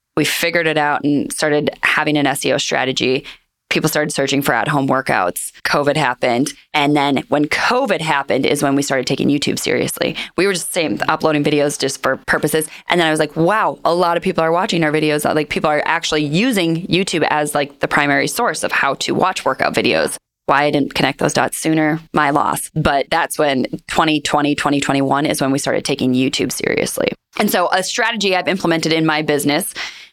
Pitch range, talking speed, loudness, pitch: 145-165 Hz, 200 wpm, -16 LUFS, 150 Hz